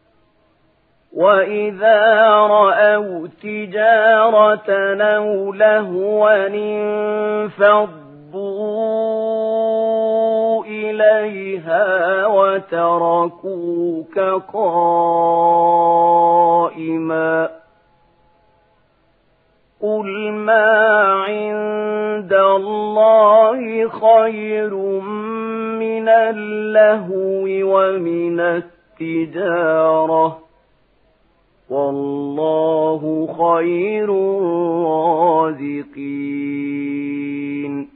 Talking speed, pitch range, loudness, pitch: 30 wpm, 170-215 Hz, -16 LUFS, 195 Hz